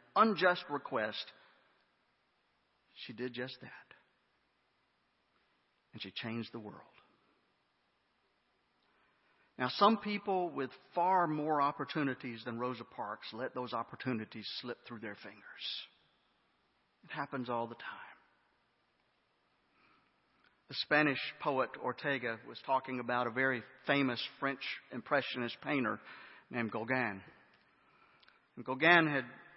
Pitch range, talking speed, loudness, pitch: 115-140 Hz, 105 wpm, -35 LUFS, 125 Hz